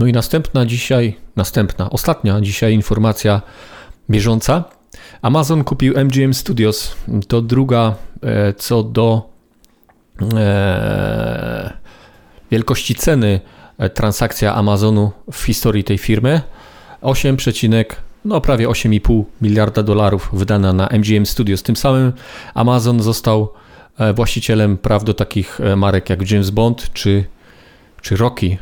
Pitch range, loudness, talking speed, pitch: 105-125 Hz, -16 LUFS, 105 wpm, 110 Hz